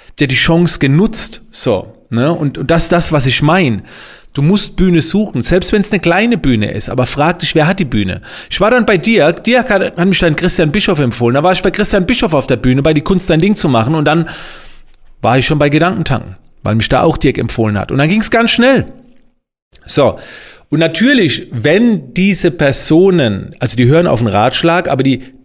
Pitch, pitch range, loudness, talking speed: 165 Hz, 135-195 Hz, -12 LUFS, 220 wpm